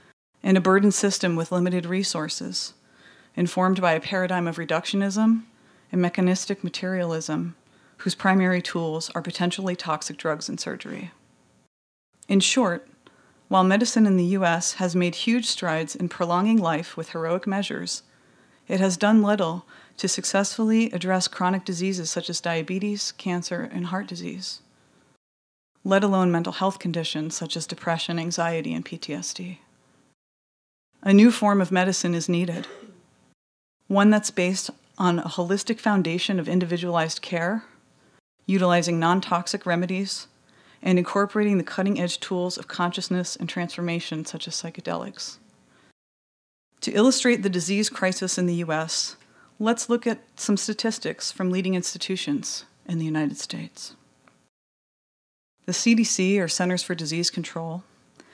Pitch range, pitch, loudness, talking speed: 170-195 Hz, 180 Hz, -24 LUFS, 135 wpm